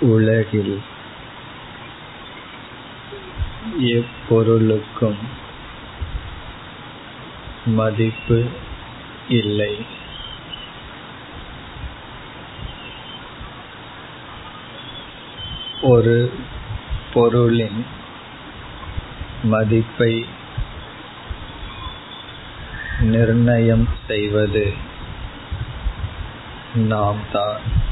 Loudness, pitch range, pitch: -20 LUFS, 105-115 Hz, 110 Hz